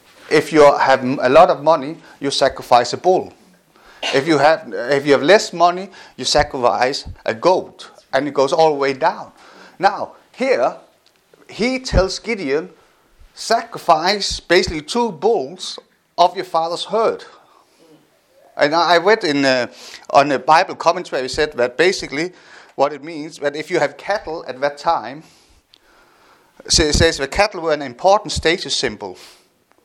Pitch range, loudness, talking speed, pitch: 140-185 Hz, -17 LUFS, 150 wpm, 160 Hz